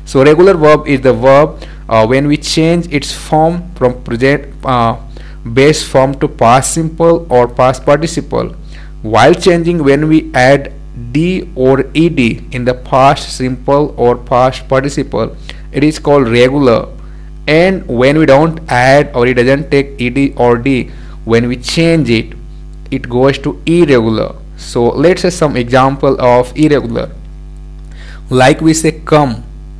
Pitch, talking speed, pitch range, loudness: 140 Hz, 145 wpm, 125-155 Hz, -10 LUFS